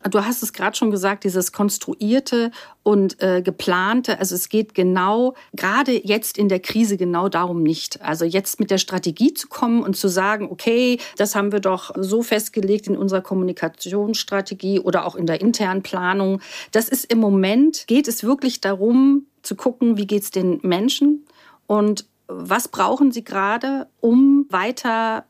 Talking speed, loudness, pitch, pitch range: 170 wpm, -19 LUFS, 210 Hz, 190-240 Hz